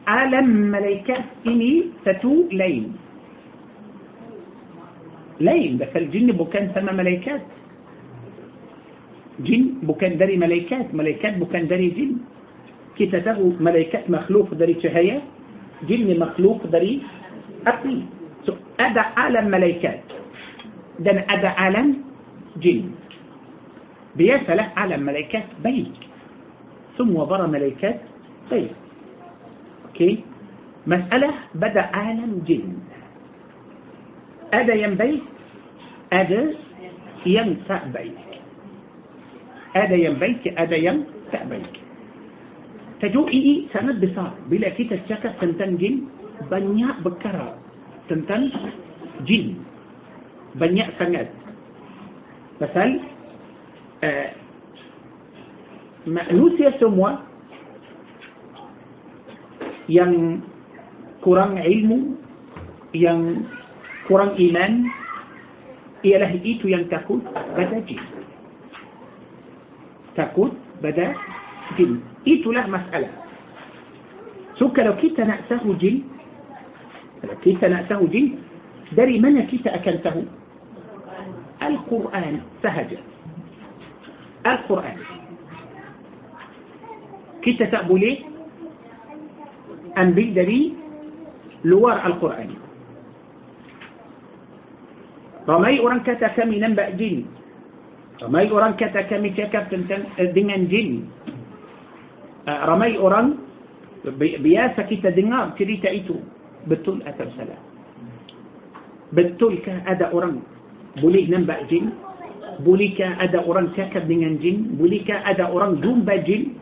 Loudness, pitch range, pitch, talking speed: -20 LUFS, 180-245 Hz, 205 Hz, 80 wpm